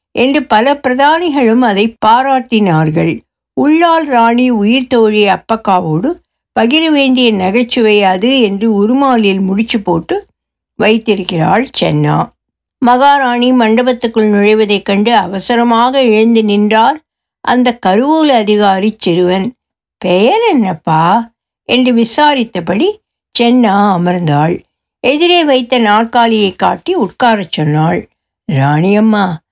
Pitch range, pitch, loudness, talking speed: 195-255 Hz, 230 Hz, -10 LUFS, 90 wpm